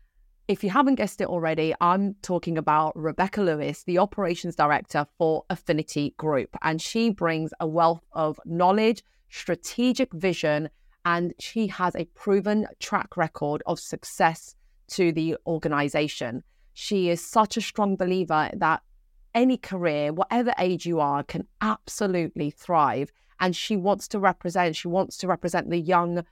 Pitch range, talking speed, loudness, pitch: 160-195 Hz, 150 wpm, -25 LUFS, 175 Hz